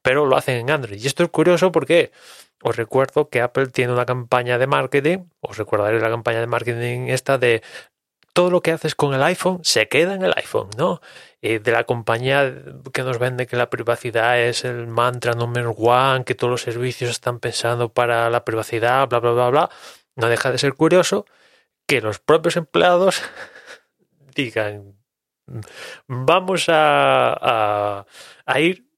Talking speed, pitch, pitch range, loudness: 170 wpm, 125 Hz, 120-150 Hz, -19 LUFS